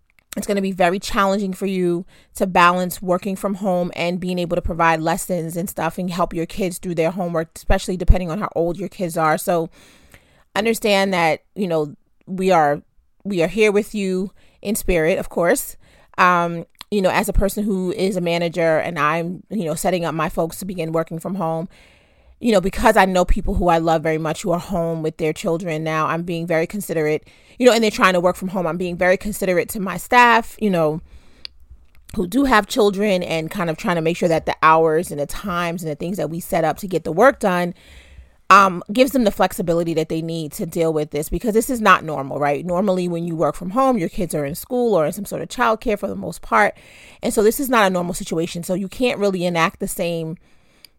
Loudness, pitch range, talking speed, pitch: -19 LUFS, 165-200 Hz, 235 wpm, 180 Hz